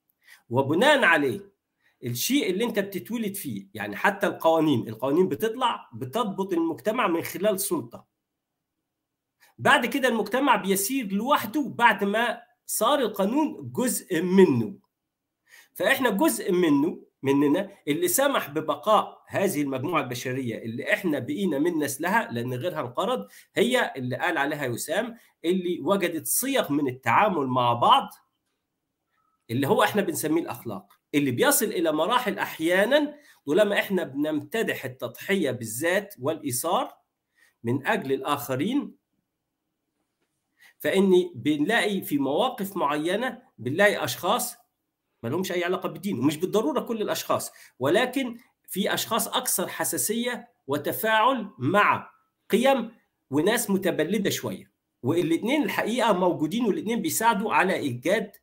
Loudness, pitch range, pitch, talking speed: -25 LUFS, 150-235 Hz, 195 Hz, 115 wpm